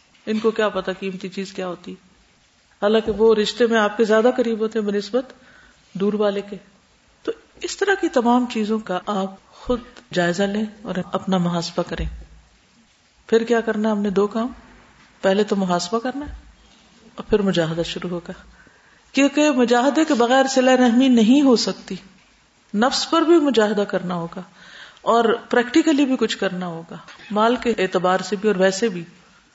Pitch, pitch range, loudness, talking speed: 215 Hz, 190-245 Hz, -20 LUFS, 175 wpm